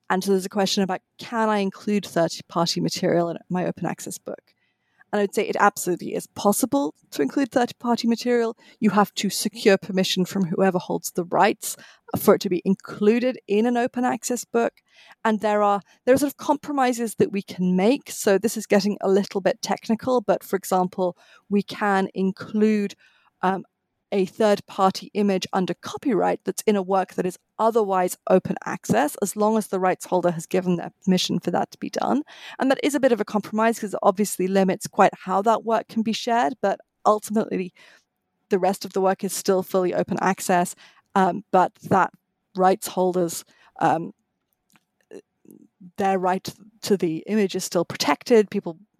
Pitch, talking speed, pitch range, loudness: 200 Hz, 185 wpm, 185-220 Hz, -23 LUFS